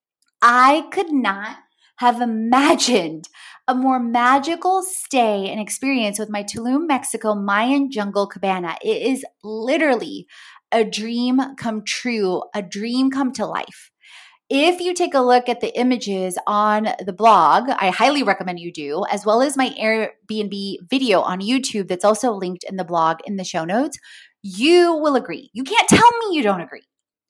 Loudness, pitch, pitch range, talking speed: -19 LUFS, 230 Hz, 200-265 Hz, 165 wpm